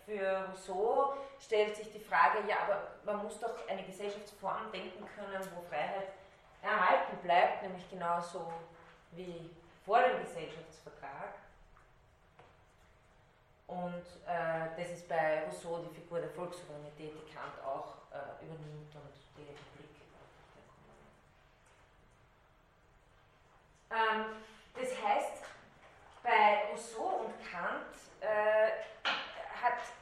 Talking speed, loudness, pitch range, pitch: 105 wpm, -36 LUFS, 160-210 Hz, 180 Hz